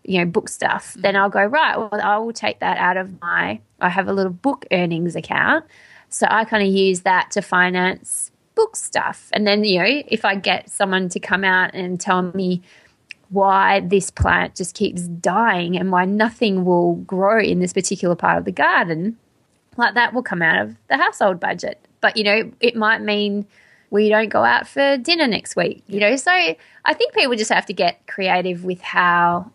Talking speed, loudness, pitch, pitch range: 205 wpm, -18 LUFS, 195 Hz, 180-220 Hz